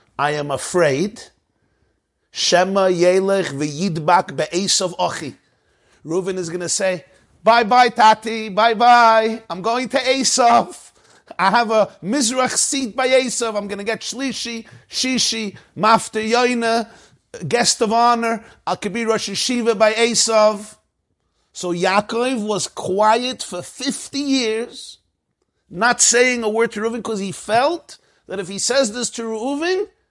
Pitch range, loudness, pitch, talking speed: 195-240 Hz, -18 LUFS, 225 Hz, 135 wpm